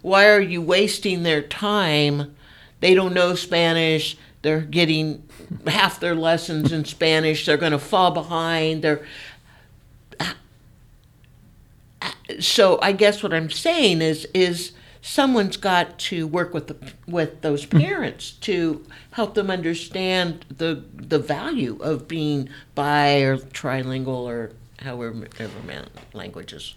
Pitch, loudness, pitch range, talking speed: 155 Hz, -21 LUFS, 145-175 Hz, 130 wpm